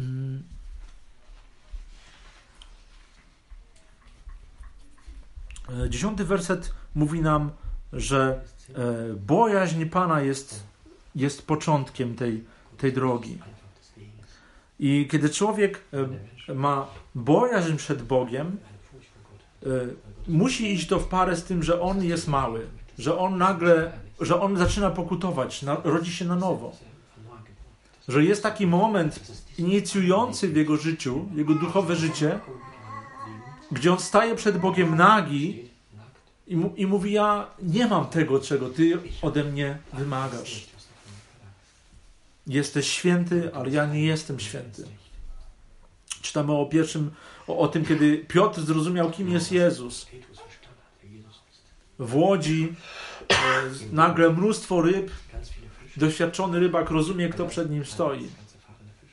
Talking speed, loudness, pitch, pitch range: 100 wpm, -24 LUFS, 145 Hz, 120-175 Hz